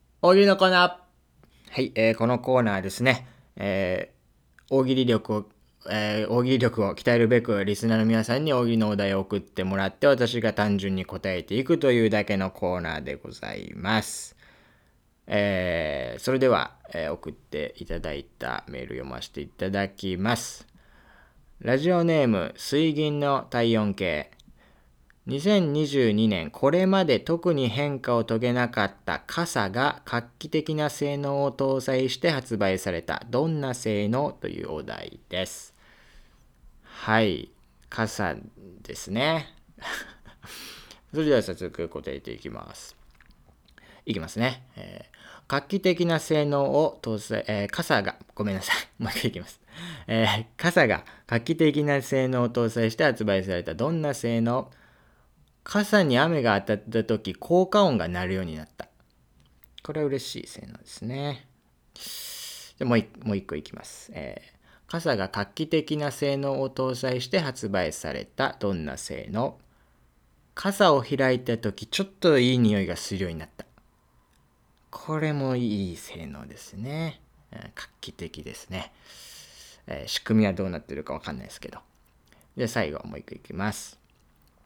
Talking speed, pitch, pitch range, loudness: 275 characters per minute, 115 Hz, 95-140 Hz, -26 LUFS